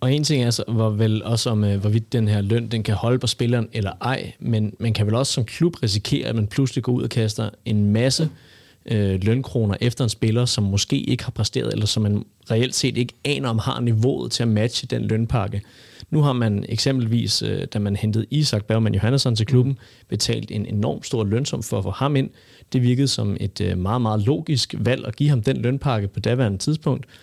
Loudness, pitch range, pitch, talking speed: -22 LUFS, 105-130 Hz, 115 Hz, 225 wpm